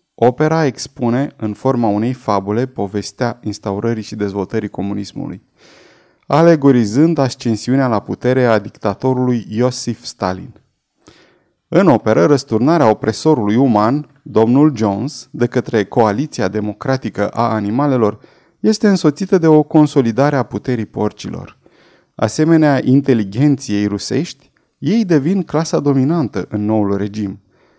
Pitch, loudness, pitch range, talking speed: 120 Hz, -15 LUFS, 105-145 Hz, 110 wpm